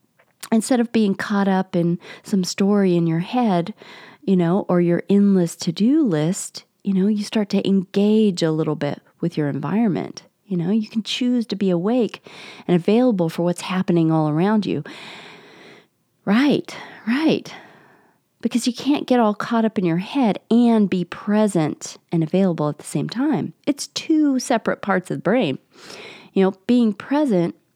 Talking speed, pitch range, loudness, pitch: 170 wpm, 175-230 Hz, -20 LUFS, 200 Hz